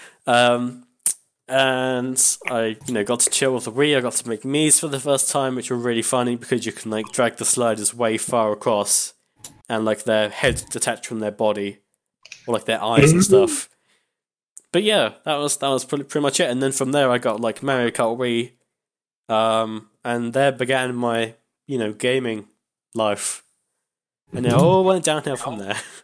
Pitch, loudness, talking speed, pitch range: 125 Hz, -20 LUFS, 195 wpm, 115-140 Hz